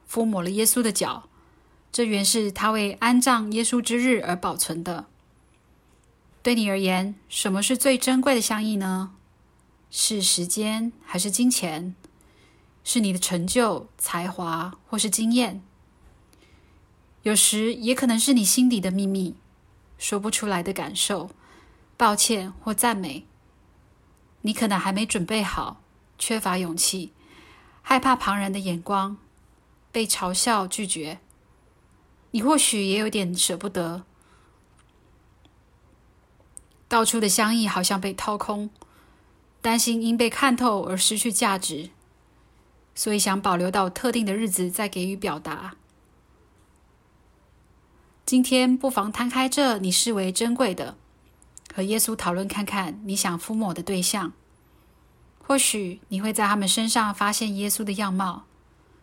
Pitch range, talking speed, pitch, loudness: 185-230 Hz, 195 characters per minute, 205 Hz, -23 LUFS